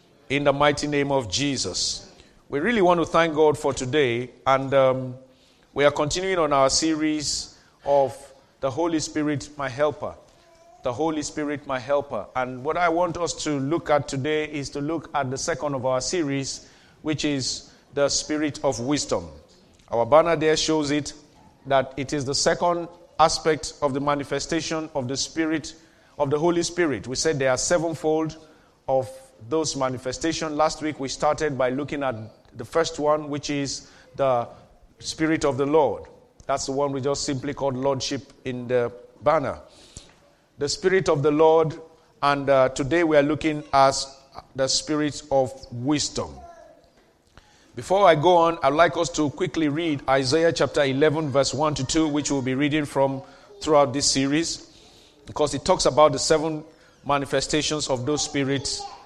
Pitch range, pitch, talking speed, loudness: 135-160 Hz, 145 Hz, 170 wpm, -23 LUFS